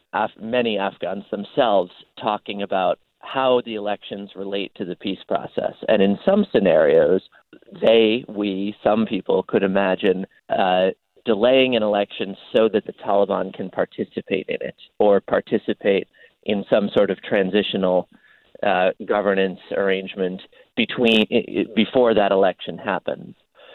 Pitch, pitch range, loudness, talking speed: 105 Hz, 95-115 Hz, -21 LUFS, 130 wpm